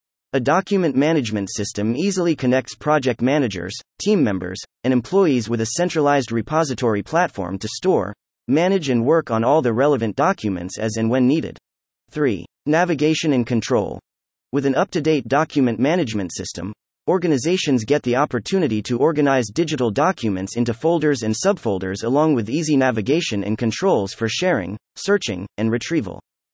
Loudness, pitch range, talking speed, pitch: -20 LUFS, 110-155 Hz, 150 wpm, 130 Hz